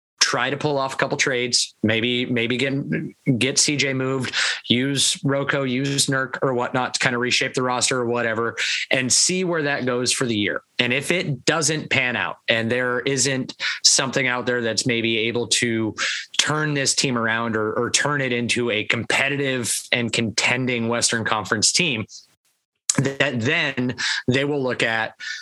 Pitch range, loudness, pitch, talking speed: 120-140 Hz, -20 LUFS, 125 Hz, 175 wpm